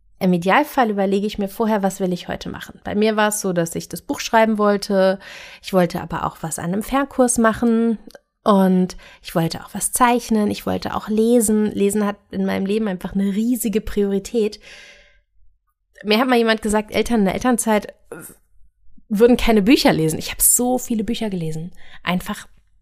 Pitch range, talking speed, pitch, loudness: 185-225 Hz, 185 wpm, 210 Hz, -19 LUFS